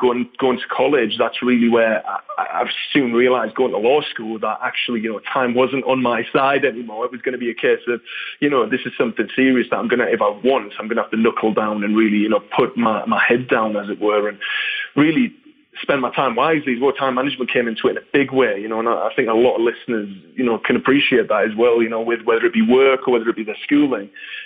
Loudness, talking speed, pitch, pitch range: -18 LUFS, 265 wpm, 120 Hz, 115-135 Hz